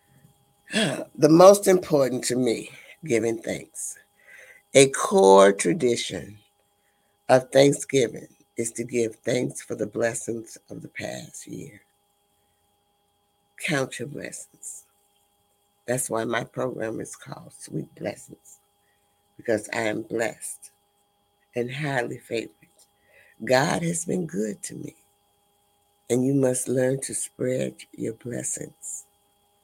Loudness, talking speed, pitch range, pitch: -24 LUFS, 110 wpm, 100-130 Hz, 115 Hz